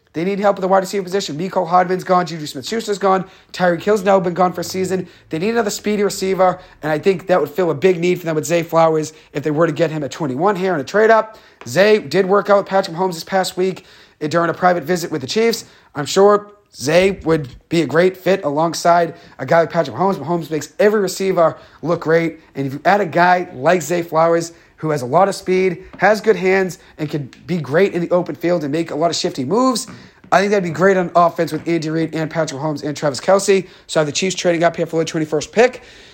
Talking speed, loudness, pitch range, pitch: 250 wpm, -17 LUFS, 160-190 Hz, 175 Hz